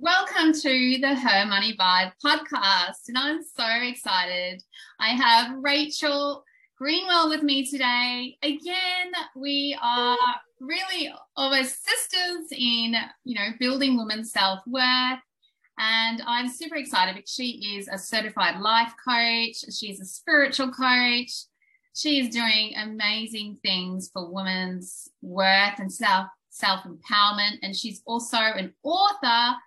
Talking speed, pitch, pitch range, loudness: 120 wpm, 245 Hz, 210-285 Hz, -23 LUFS